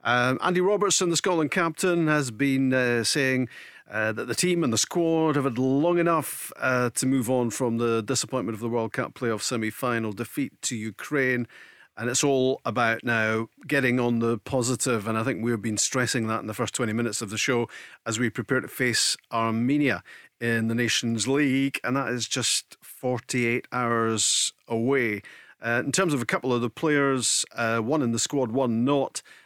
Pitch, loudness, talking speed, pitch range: 125 Hz, -25 LUFS, 195 wpm, 115-140 Hz